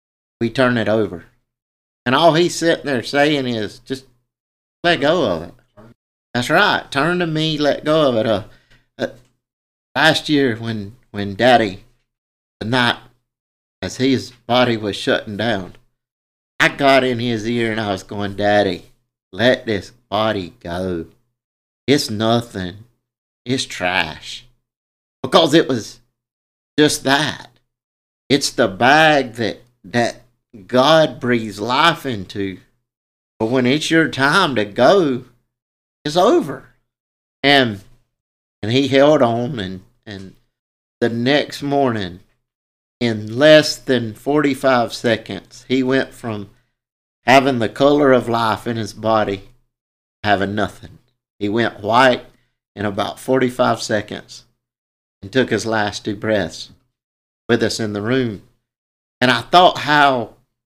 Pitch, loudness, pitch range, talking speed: 120 Hz, -17 LUFS, 105-130 Hz, 135 wpm